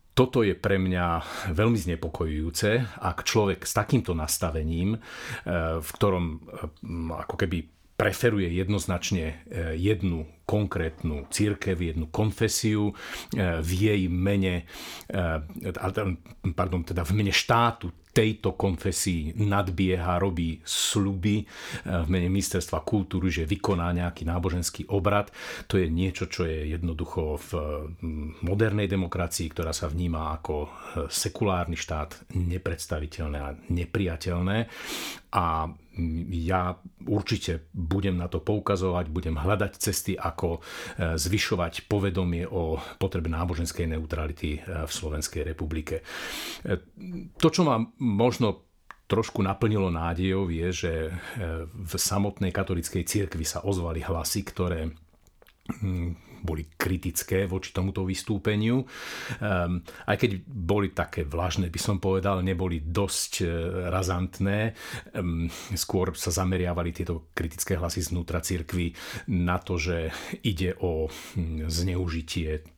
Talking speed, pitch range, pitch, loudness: 110 wpm, 85-100 Hz, 90 Hz, -28 LUFS